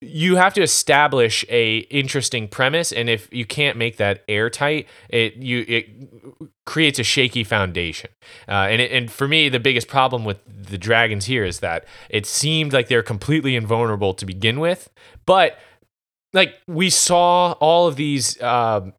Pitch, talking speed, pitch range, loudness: 125 Hz, 170 wpm, 110-150 Hz, -18 LUFS